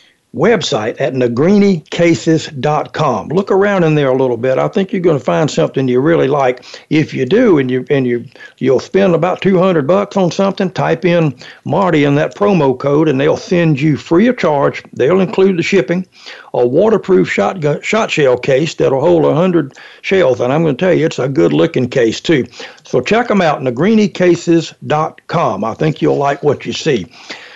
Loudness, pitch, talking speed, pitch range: -13 LUFS, 165 Hz, 190 wpm, 145-190 Hz